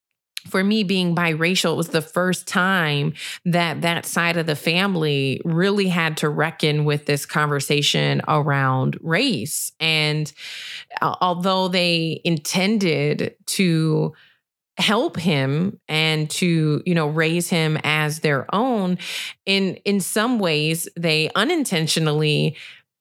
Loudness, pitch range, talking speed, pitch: -20 LUFS, 150-185 Hz, 120 wpm, 165 Hz